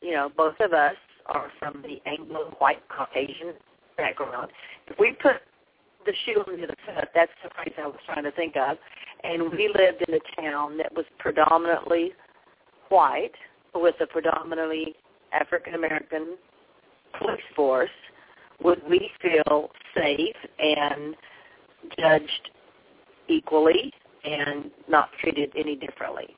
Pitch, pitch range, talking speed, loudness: 160 Hz, 150-175 Hz, 130 wpm, -25 LUFS